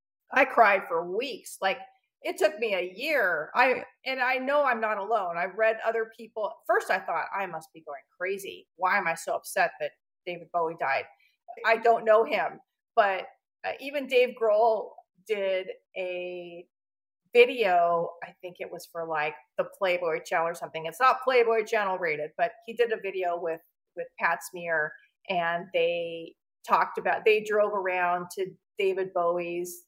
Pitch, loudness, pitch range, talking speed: 195 Hz, -27 LUFS, 175-245 Hz, 170 wpm